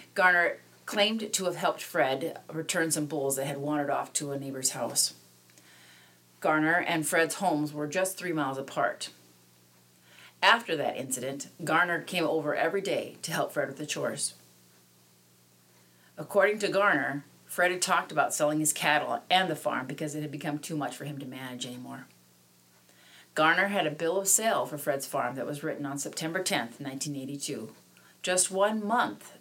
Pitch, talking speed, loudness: 140 Hz, 170 wpm, -29 LUFS